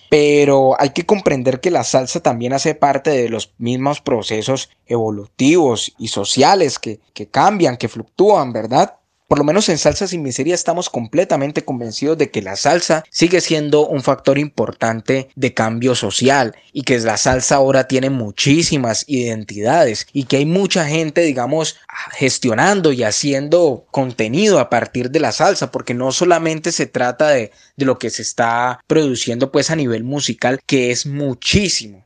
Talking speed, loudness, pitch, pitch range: 165 wpm, -16 LUFS, 135 Hz, 125-155 Hz